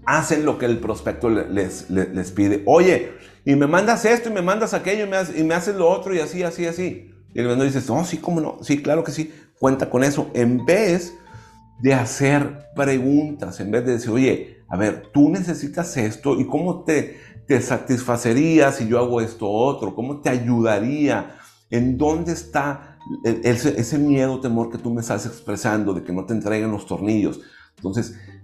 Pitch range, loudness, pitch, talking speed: 115-155 Hz, -21 LUFS, 135 Hz, 205 wpm